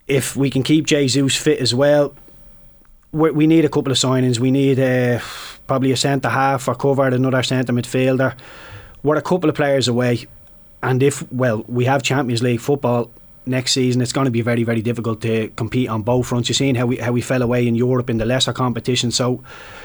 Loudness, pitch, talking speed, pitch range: -18 LUFS, 130 Hz, 210 wpm, 120-135 Hz